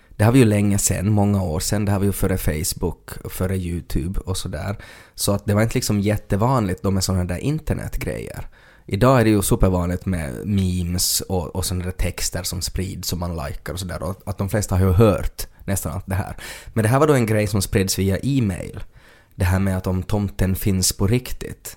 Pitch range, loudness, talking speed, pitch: 90-105 Hz, -21 LUFS, 230 wpm, 95 Hz